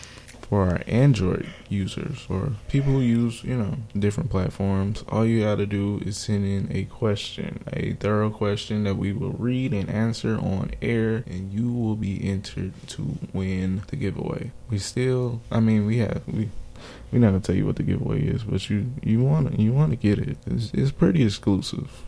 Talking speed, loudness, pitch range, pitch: 195 wpm, -25 LUFS, 100-125 Hz, 110 Hz